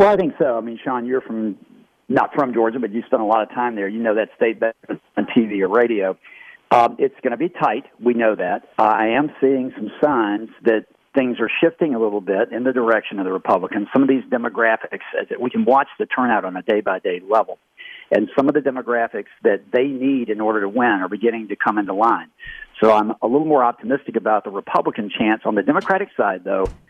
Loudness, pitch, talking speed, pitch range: -19 LUFS, 120 Hz, 240 wpm, 110-135 Hz